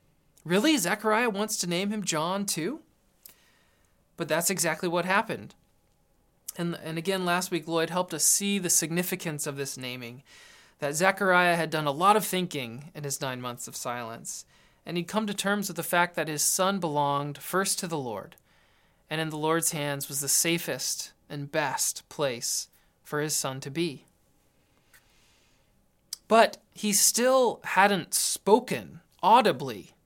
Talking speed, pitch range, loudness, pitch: 160 wpm, 145-185 Hz, -26 LUFS, 165 Hz